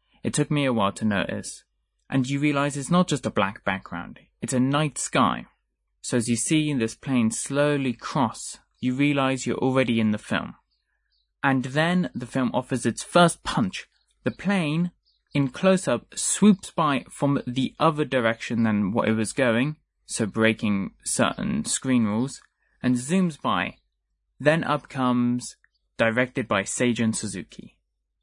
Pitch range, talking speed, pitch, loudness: 115-145 Hz, 155 wpm, 130 Hz, -24 LUFS